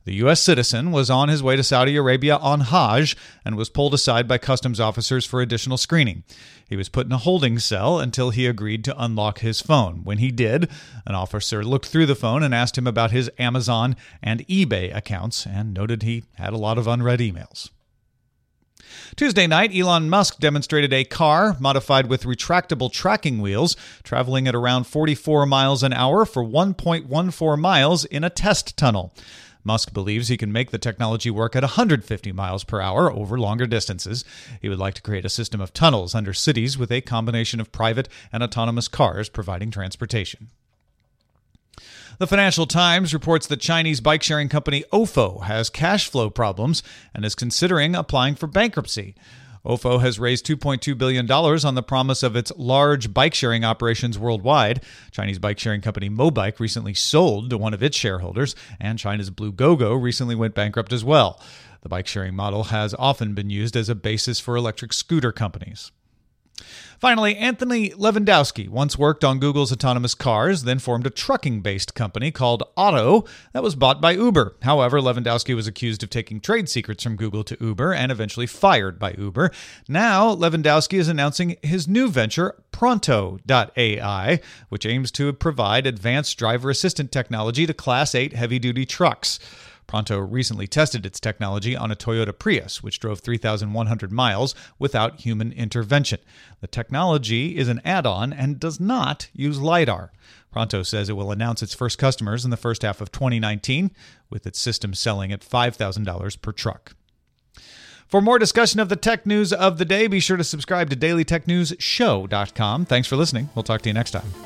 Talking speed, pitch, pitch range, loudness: 170 wpm, 125 Hz, 110-150 Hz, -21 LUFS